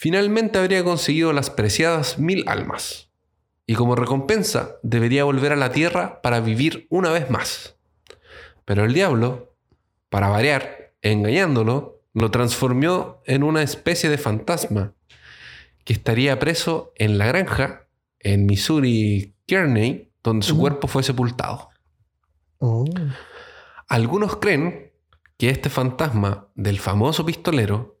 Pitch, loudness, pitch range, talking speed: 125 Hz, -21 LUFS, 105-155 Hz, 120 wpm